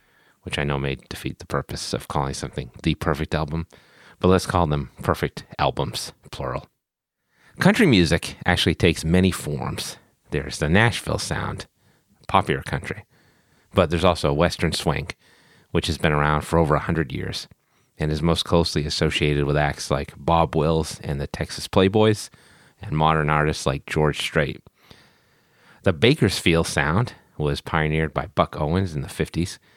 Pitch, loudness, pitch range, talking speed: 80 Hz, -22 LUFS, 75-85 Hz, 155 wpm